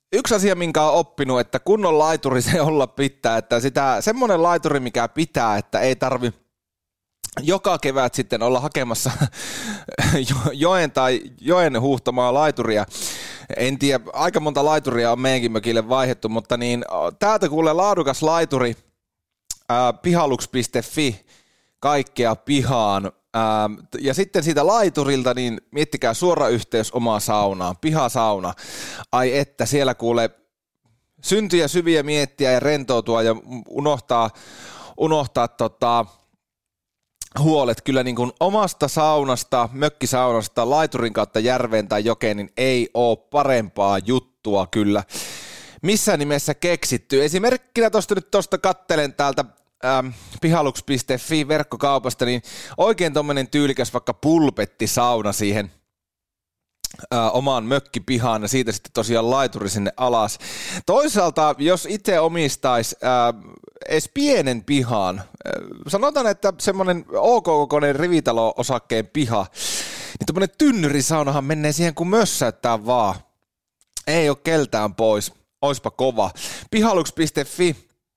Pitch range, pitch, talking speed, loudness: 115-155 Hz, 130 Hz, 115 wpm, -20 LUFS